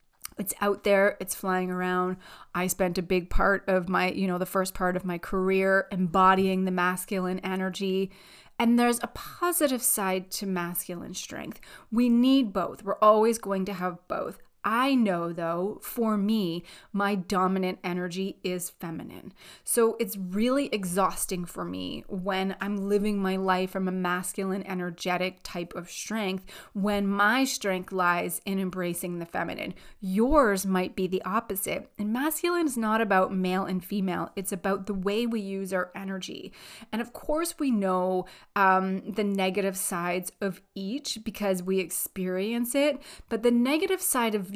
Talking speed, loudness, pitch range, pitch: 160 wpm, -27 LUFS, 185-215 Hz, 195 Hz